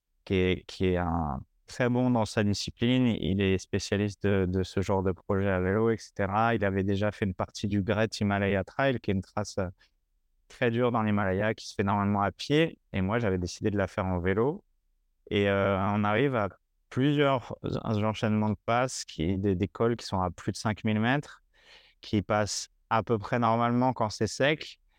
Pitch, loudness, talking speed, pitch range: 100 Hz, -28 LUFS, 200 wpm, 95-115 Hz